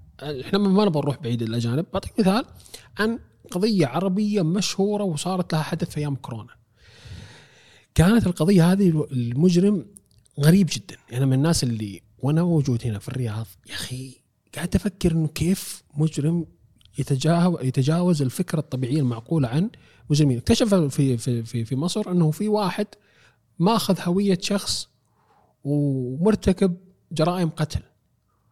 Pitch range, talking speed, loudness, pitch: 125-185 Hz, 125 wpm, -23 LUFS, 155 Hz